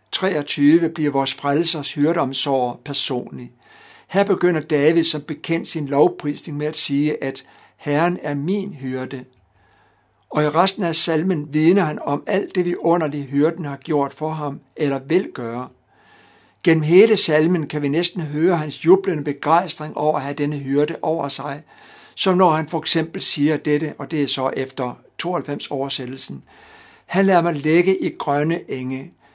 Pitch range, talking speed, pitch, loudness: 140-175 Hz, 160 wpm, 155 Hz, -20 LUFS